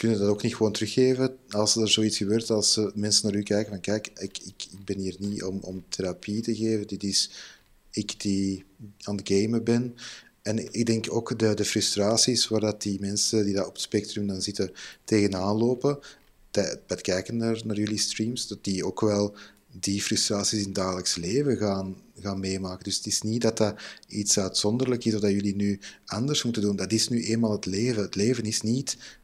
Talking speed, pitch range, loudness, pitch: 210 wpm, 100-115 Hz, -26 LUFS, 105 Hz